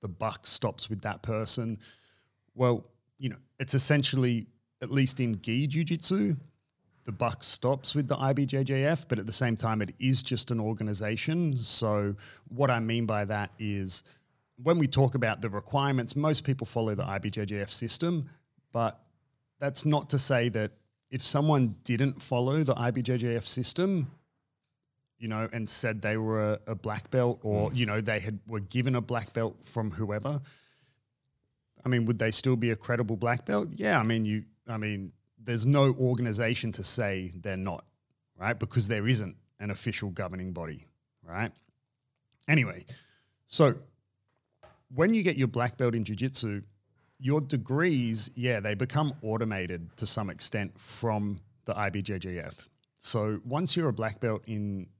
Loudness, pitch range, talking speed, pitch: -28 LUFS, 110-135 Hz, 160 wpm, 120 Hz